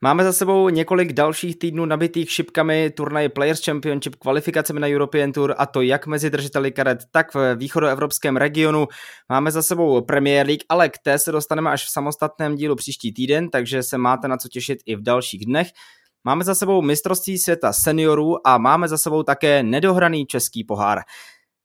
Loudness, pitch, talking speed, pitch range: -19 LUFS, 150 Hz, 180 wpm, 135-160 Hz